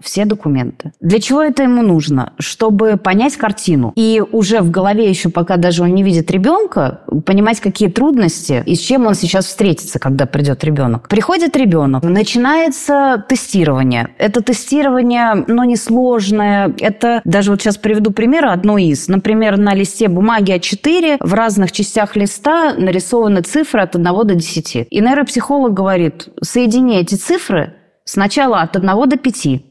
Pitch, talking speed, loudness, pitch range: 205 Hz, 155 wpm, -13 LUFS, 175-240 Hz